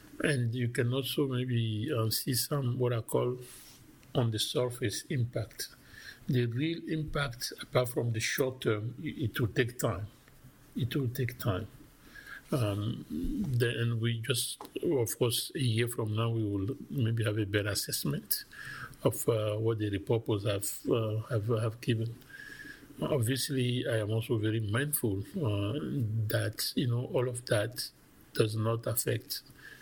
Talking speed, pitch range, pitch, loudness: 150 wpm, 110-130 Hz, 120 Hz, -32 LUFS